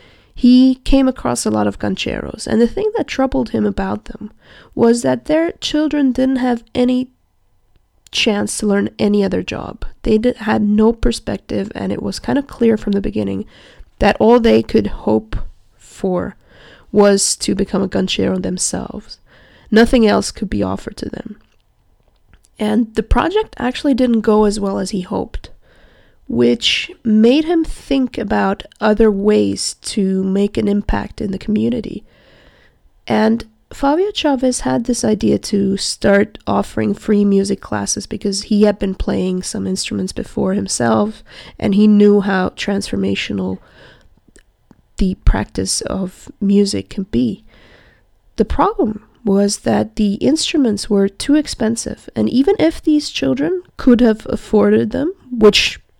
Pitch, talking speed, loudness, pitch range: 210 Hz, 145 wpm, -16 LUFS, 190-250 Hz